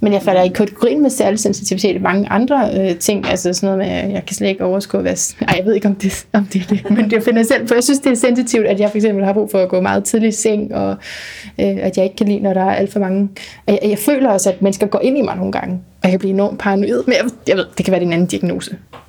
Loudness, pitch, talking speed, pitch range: -15 LUFS, 200 Hz, 320 wpm, 195-220 Hz